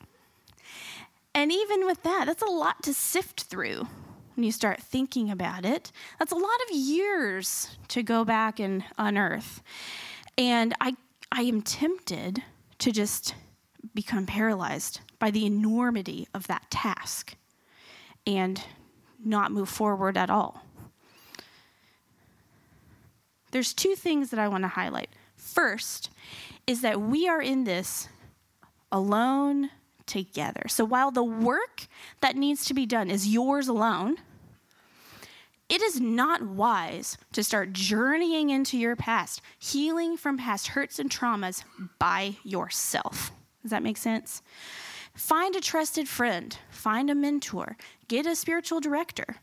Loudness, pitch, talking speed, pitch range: -28 LUFS, 245 Hz, 130 wpm, 215-295 Hz